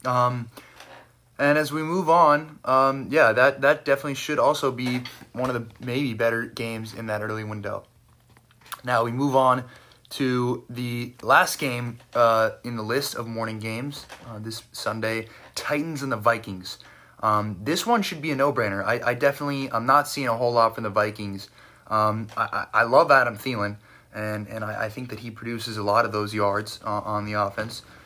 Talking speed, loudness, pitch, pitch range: 190 wpm, -24 LUFS, 120 Hz, 110-135 Hz